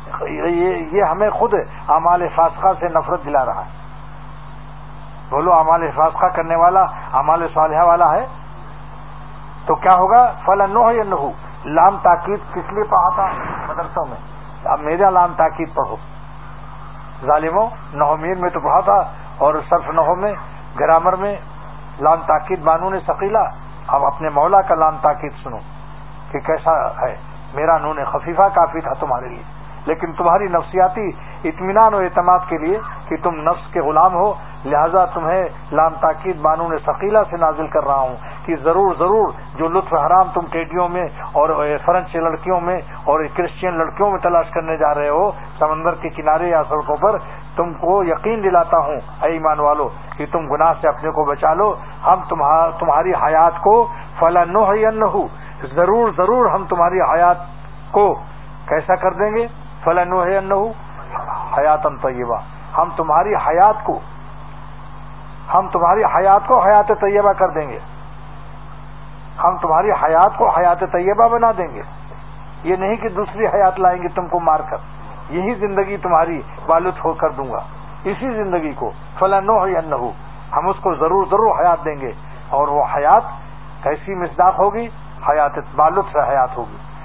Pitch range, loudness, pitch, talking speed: 155-190 Hz, -16 LUFS, 170 Hz, 155 wpm